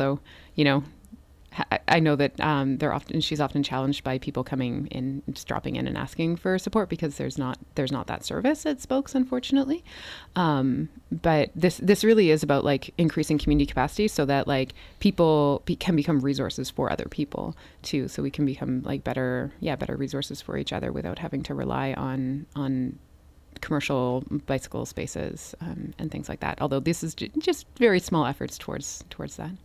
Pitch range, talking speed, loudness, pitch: 135-165 Hz, 190 wpm, -26 LUFS, 145 Hz